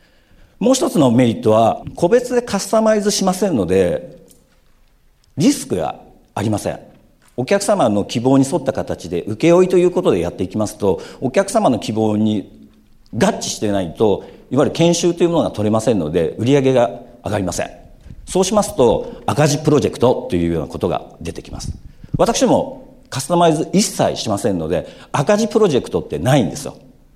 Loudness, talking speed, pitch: -17 LUFS, 370 characters per minute, 155 Hz